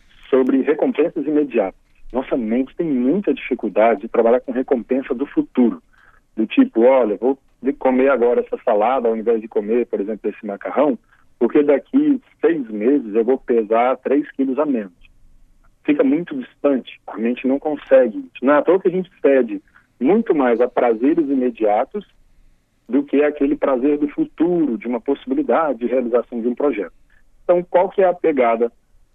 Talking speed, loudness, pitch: 160 wpm, -18 LUFS, 145 Hz